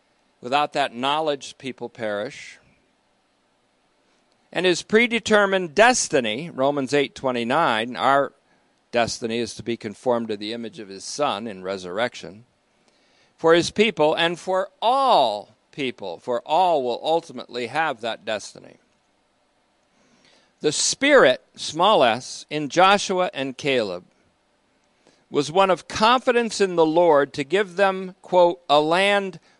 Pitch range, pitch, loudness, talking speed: 120-185 Hz, 150 Hz, -21 LUFS, 125 wpm